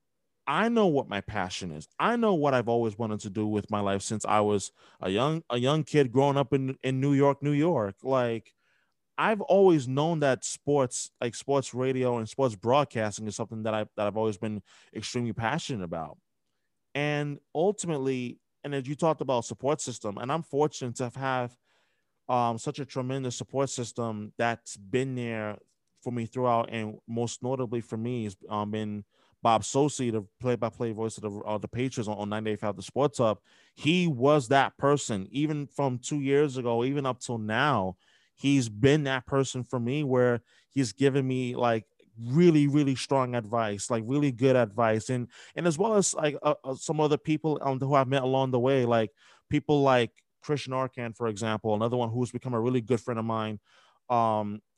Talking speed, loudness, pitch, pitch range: 190 wpm, -28 LUFS, 125 Hz, 115-140 Hz